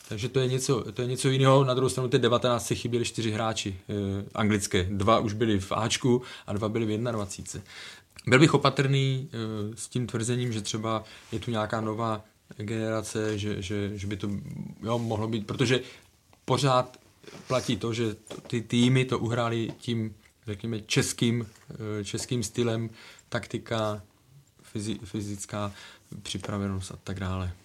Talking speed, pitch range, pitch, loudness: 160 wpm, 105-125 Hz, 110 Hz, -28 LUFS